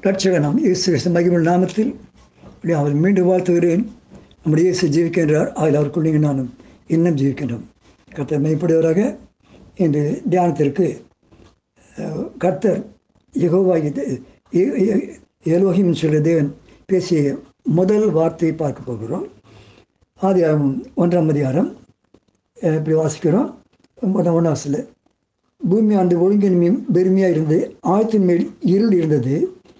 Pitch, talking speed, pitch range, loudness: 170 Hz, 95 wpm, 155-185 Hz, -18 LUFS